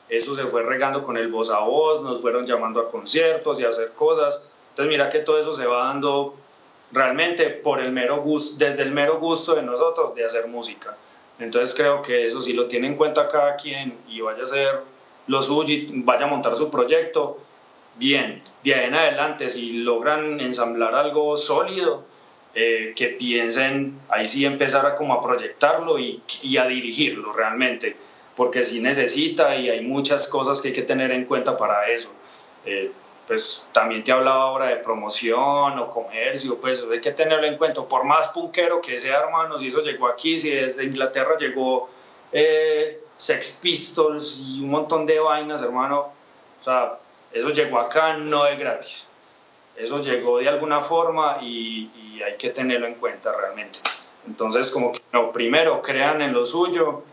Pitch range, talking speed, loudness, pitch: 120-160 Hz, 180 wpm, -21 LUFS, 140 Hz